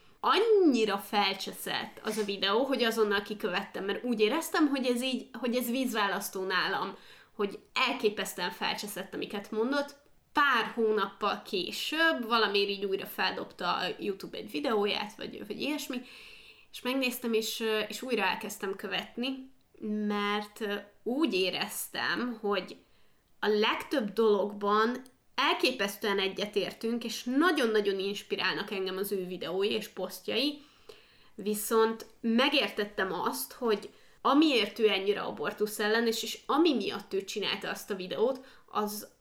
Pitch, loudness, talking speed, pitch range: 215 Hz, -30 LUFS, 125 wpm, 200-245 Hz